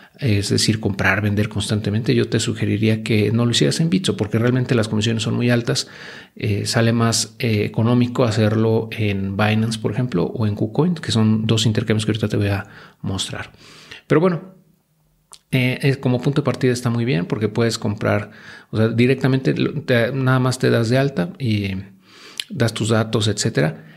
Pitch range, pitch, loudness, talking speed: 105-130 Hz, 115 Hz, -19 LUFS, 185 wpm